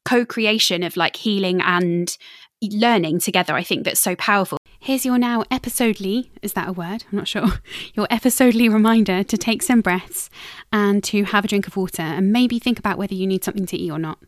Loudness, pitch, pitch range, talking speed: -19 LUFS, 205 Hz, 185-230 Hz, 205 wpm